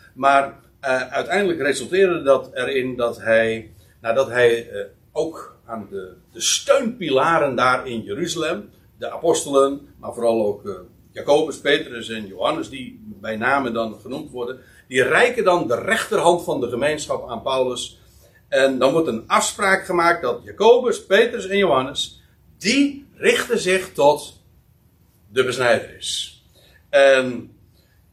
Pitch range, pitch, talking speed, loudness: 115-190 Hz, 135 Hz, 140 wpm, -20 LUFS